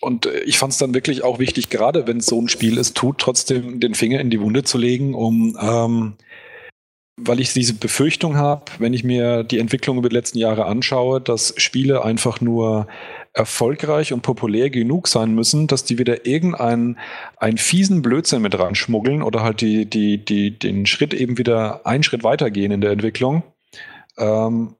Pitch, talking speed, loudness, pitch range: 120 Hz, 185 wpm, -18 LUFS, 115-130 Hz